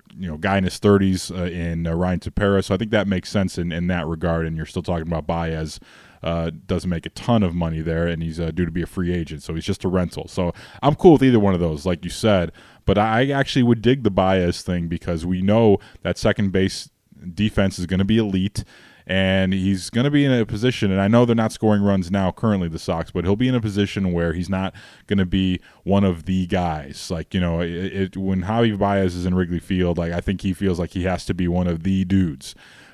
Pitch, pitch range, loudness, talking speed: 95 Hz, 85-100 Hz, -21 LUFS, 255 wpm